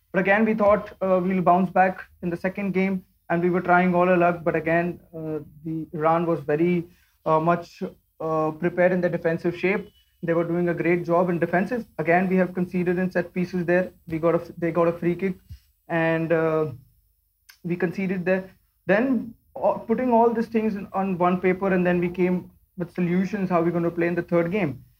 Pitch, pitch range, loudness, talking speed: 175 Hz, 170-185 Hz, -23 LUFS, 215 wpm